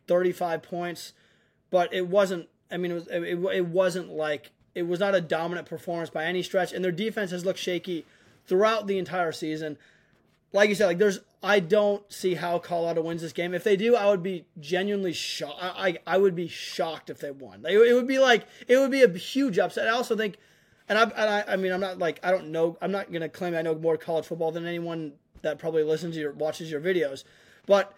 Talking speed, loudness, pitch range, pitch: 230 wpm, -26 LUFS, 165-200 Hz, 180 Hz